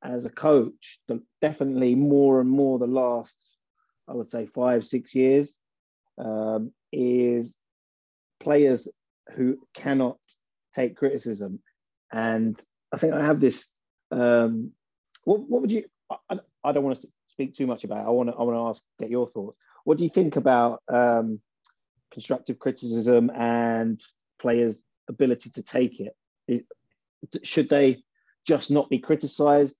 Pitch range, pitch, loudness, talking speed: 120-140 Hz, 125 Hz, -24 LUFS, 150 wpm